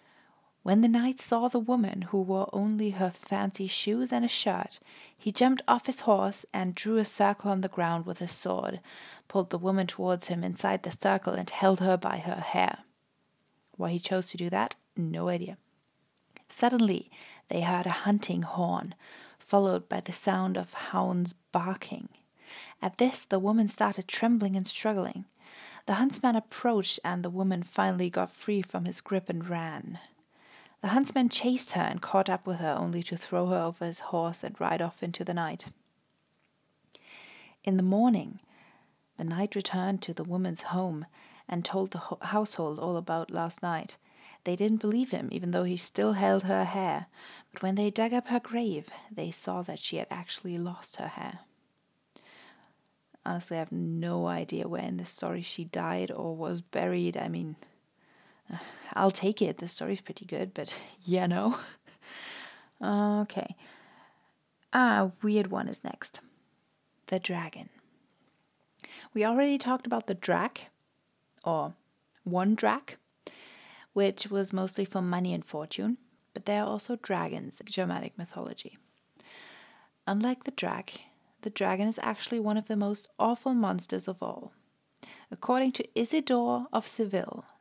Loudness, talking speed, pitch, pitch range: -27 LUFS, 160 wpm, 195 Hz, 175-215 Hz